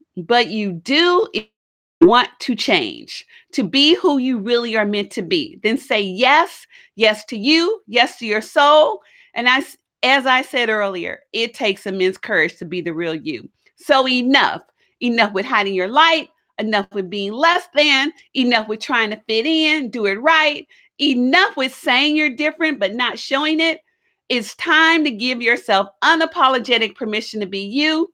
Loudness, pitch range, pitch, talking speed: -17 LUFS, 215-310 Hz, 255 Hz, 170 wpm